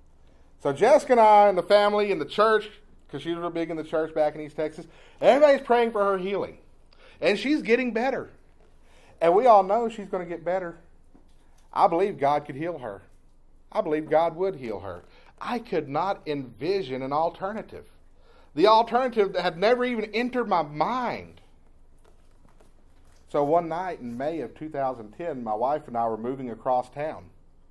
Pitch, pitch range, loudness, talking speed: 170 Hz, 130-210 Hz, -24 LUFS, 180 wpm